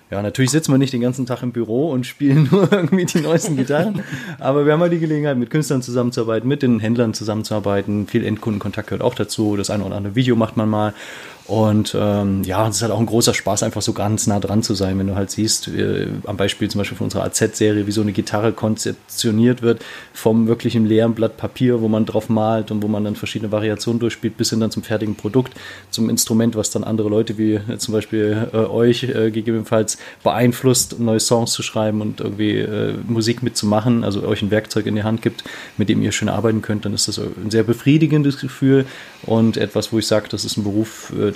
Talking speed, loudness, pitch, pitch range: 230 wpm, -18 LUFS, 110 Hz, 105-120 Hz